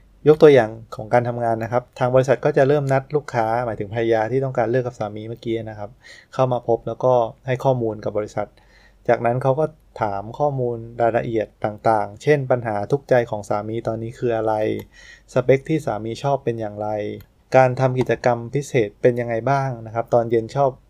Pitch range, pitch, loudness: 110-130 Hz, 120 Hz, -21 LUFS